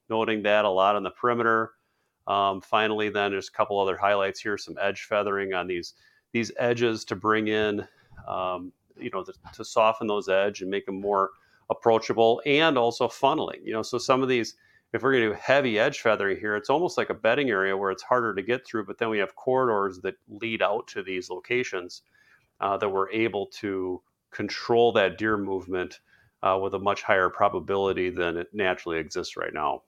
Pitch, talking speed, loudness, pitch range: 105 Hz, 205 wpm, -26 LUFS, 95-115 Hz